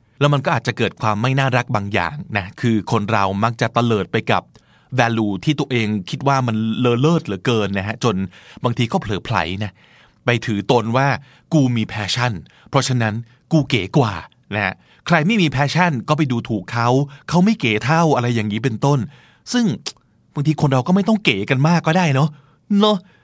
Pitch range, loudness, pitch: 110-150 Hz, -19 LUFS, 125 Hz